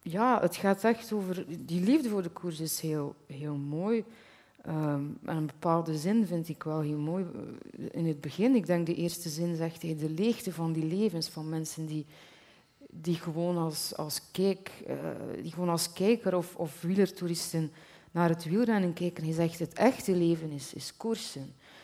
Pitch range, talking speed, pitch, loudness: 160-190 Hz, 185 wpm, 170 Hz, -31 LUFS